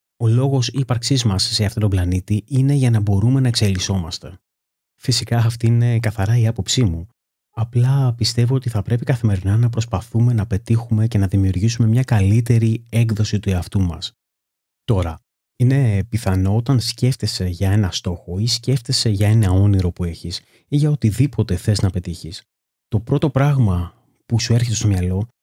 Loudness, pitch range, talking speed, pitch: -18 LUFS, 95-120 Hz, 165 wpm, 110 Hz